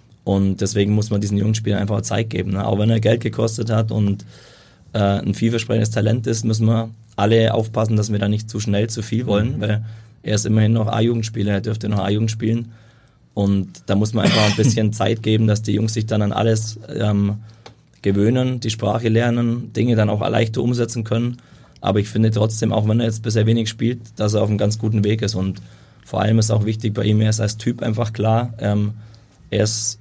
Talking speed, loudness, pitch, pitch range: 215 wpm, -19 LUFS, 110 Hz, 105-115 Hz